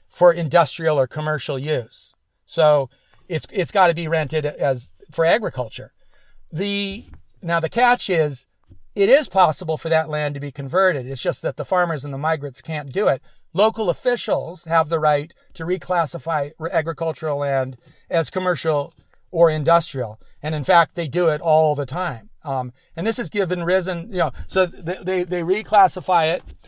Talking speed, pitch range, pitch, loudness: 170 wpm, 145-180 Hz, 165 Hz, -21 LUFS